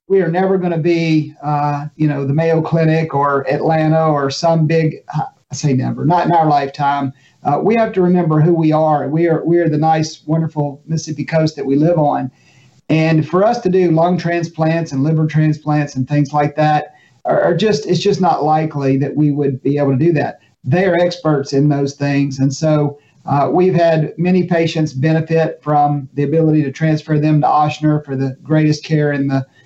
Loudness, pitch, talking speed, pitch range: -15 LUFS, 155 Hz, 205 wpm, 145-165 Hz